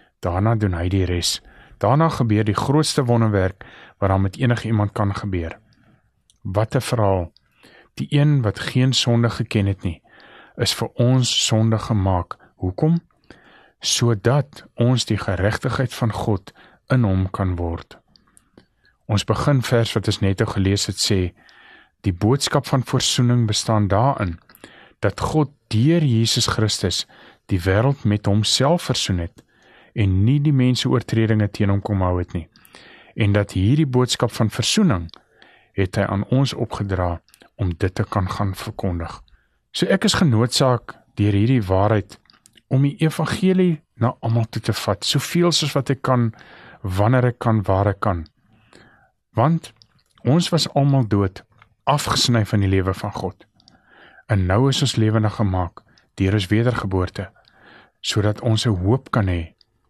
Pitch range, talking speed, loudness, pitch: 100-125 Hz, 150 wpm, -20 LUFS, 110 Hz